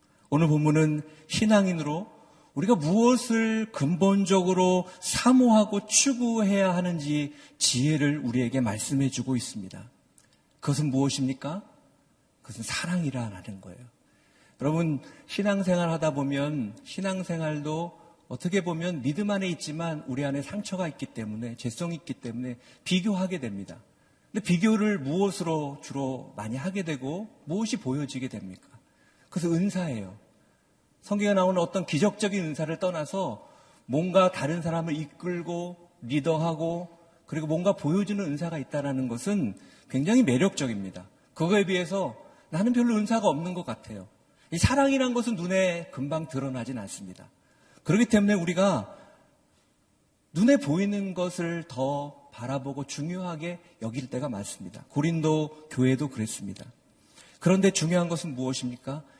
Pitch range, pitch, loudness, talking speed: 135-190 Hz, 165 Hz, -27 LUFS, 310 characters per minute